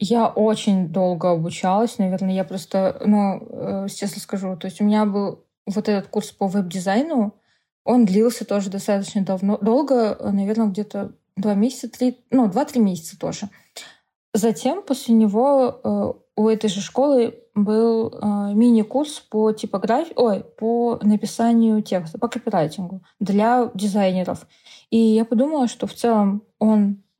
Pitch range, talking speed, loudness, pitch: 200-230 Hz, 135 wpm, -20 LUFS, 215 Hz